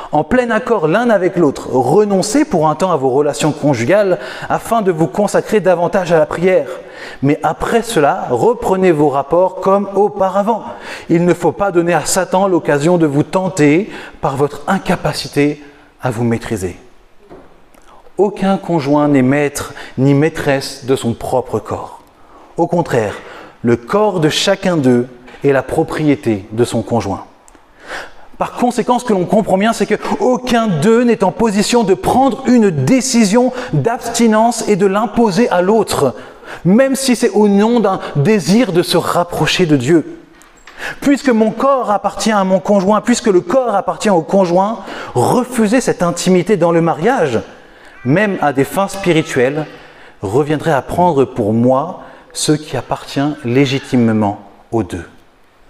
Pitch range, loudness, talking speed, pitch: 145-215 Hz, -14 LUFS, 150 wpm, 180 Hz